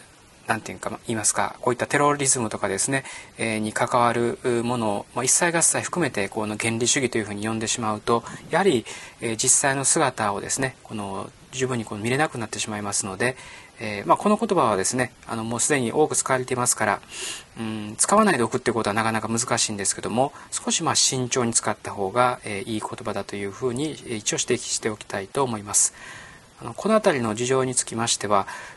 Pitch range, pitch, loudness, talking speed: 110-130 Hz, 120 Hz, -23 LUFS, 420 characters per minute